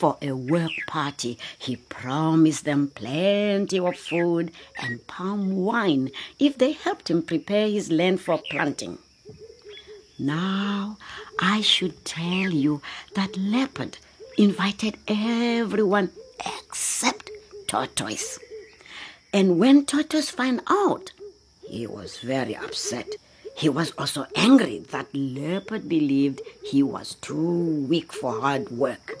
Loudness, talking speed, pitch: -24 LUFS, 115 wpm, 195 Hz